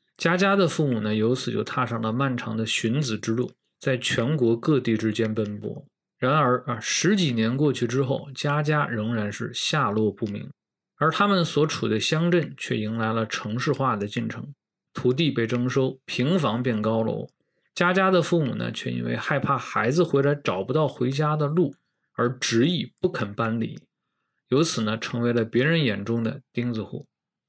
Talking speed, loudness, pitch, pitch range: 260 characters per minute, -24 LUFS, 125 Hz, 110-150 Hz